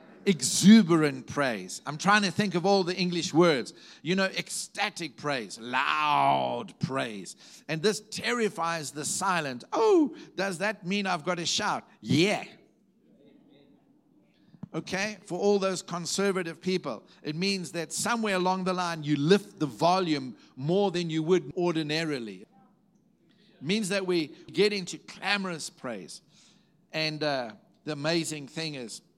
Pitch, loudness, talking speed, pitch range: 180 Hz, -28 LUFS, 140 wpm, 160-195 Hz